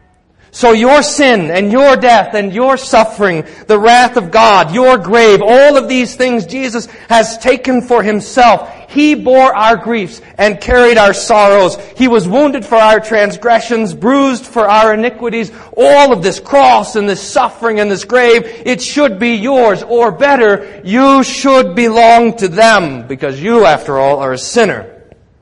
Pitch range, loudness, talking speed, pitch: 205-255 Hz, -9 LUFS, 165 wpm, 230 Hz